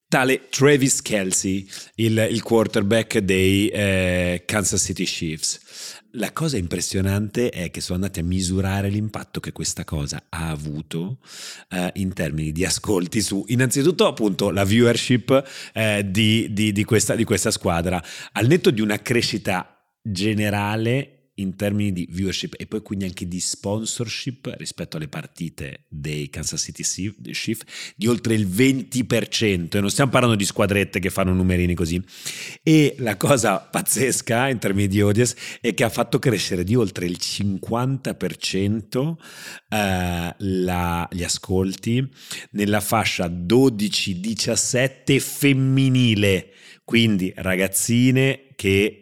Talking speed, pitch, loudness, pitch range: 135 wpm, 105 Hz, -21 LUFS, 95-120 Hz